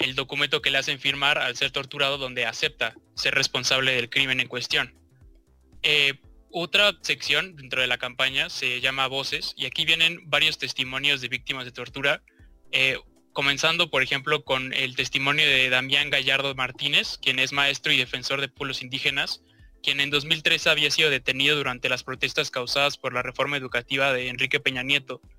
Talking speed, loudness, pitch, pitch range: 175 wpm, -23 LUFS, 135 Hz, 130-145 Hz